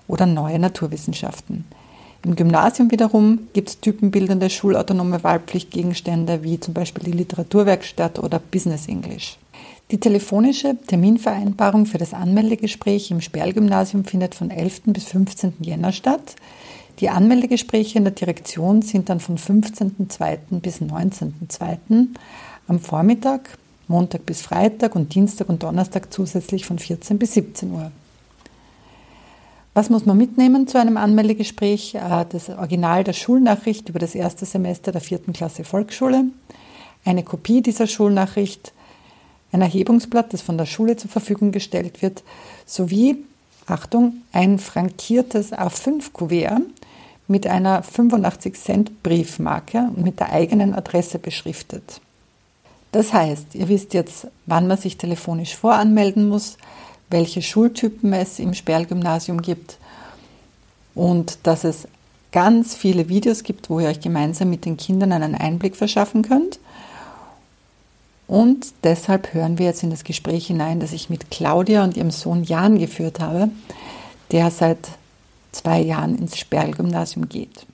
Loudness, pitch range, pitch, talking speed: -19 LUFS, 170-215 Hz, 190 Hz, 130 wpm